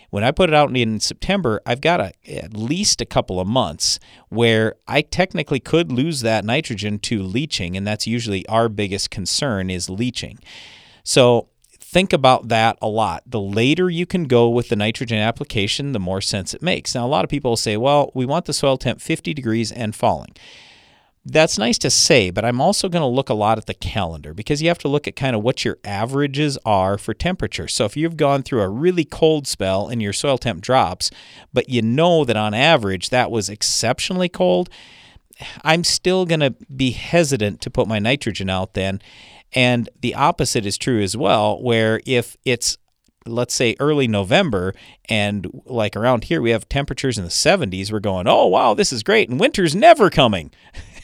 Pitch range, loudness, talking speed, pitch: 105-145 Hz, -18 LUFS, 200 wpm, 120 Hz